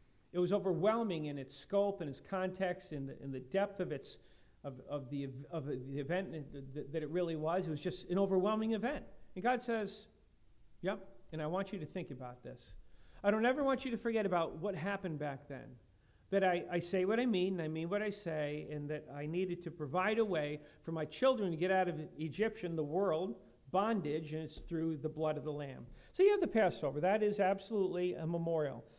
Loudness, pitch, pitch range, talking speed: -37 LUFS, 175 Hz, 150-195 Hz, 225 wpm